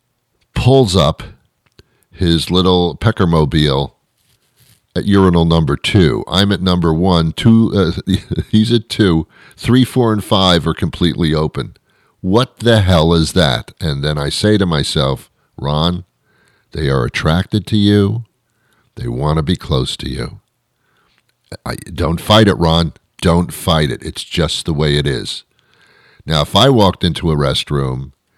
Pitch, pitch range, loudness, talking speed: 90 Hz, 80-105 Hz, -14 LUFS, 150 wpm